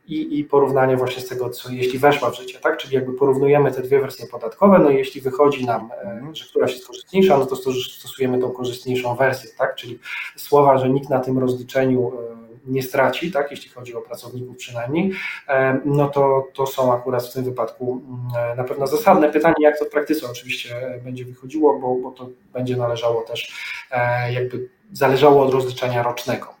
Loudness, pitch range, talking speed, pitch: -20 LUFS, 125-145 Hz, 180 wpm, 130 Hz